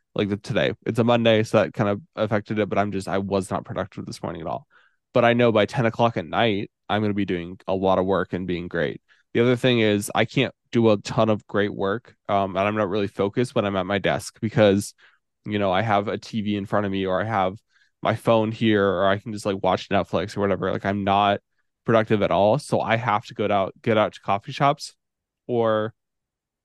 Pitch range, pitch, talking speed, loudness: 95-110 Hz, 105 Hz, 245 wpm, -23 LUFS